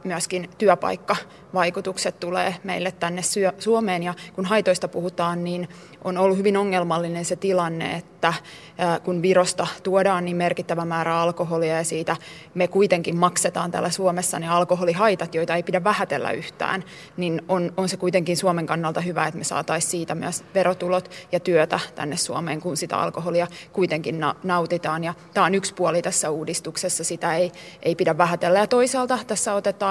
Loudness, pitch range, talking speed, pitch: -23 LUFS, 170-185 Hz, 155 wpm, 175 Hz